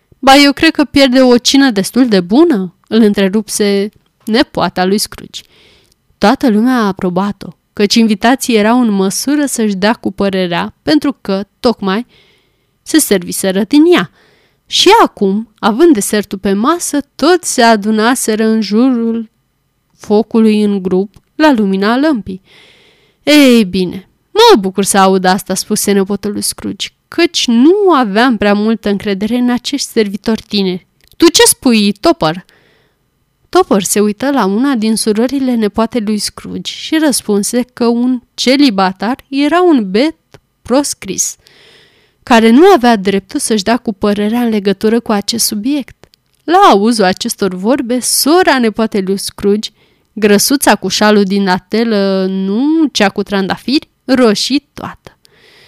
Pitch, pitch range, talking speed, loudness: 220 Hz, 200-265 Hz, 140 wpm, -11 LUFS